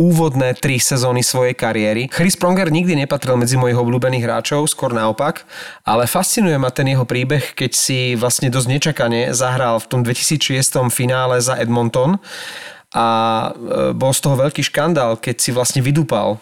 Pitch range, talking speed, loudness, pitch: 120-145 Hz, 155 wpm, -16 LUFS, 130 Hz